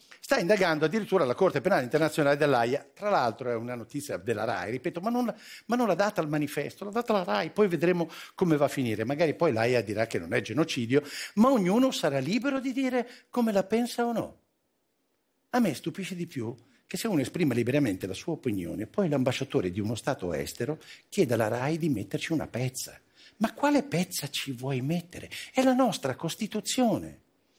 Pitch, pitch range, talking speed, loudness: 165 Hz, 140-215 Hz, 190 wpm, -28 LUFS